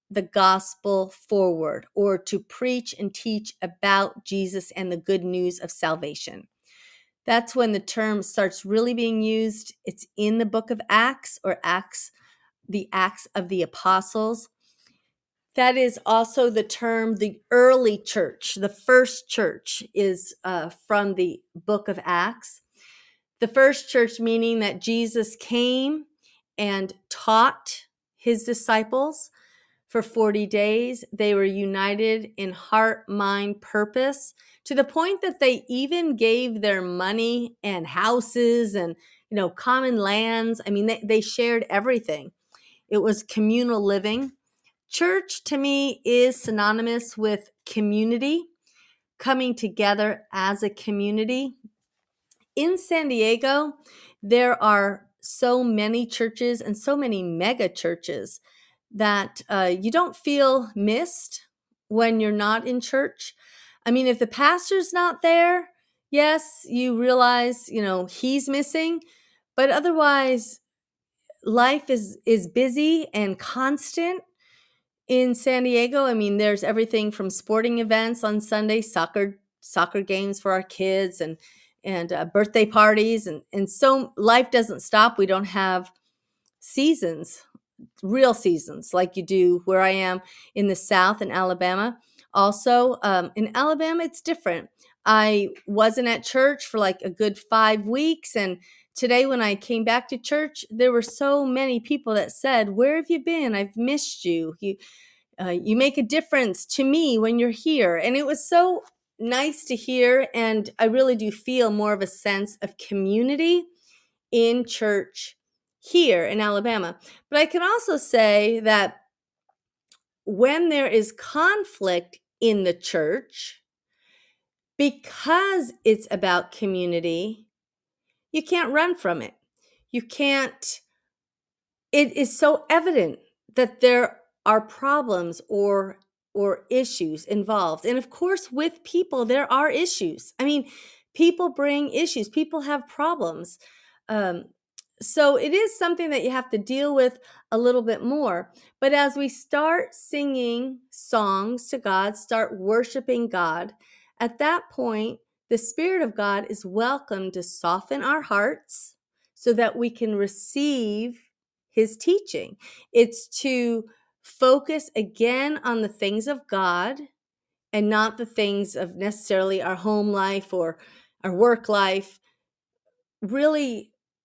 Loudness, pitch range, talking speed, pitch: -23 LUFS, 200-270 Hz, 135 wpm, 230 Hz